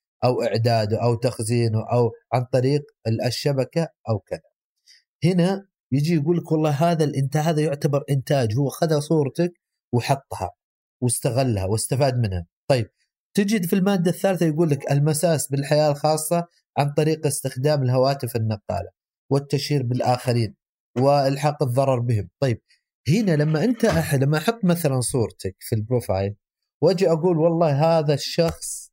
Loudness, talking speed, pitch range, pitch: -22 LUFS, 130 wpm, 125-160 Hz, 140 Hz